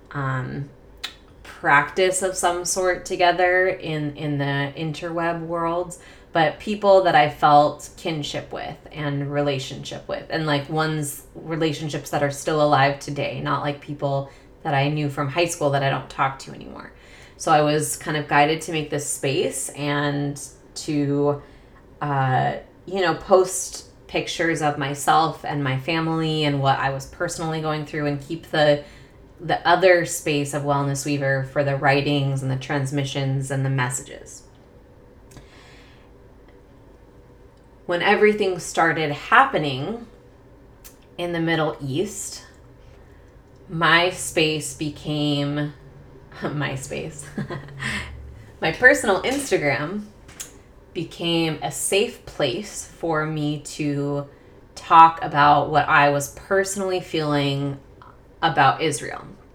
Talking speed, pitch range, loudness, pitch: 125 wpm, 140-165 Hz, -22 LUFS, 145 Hz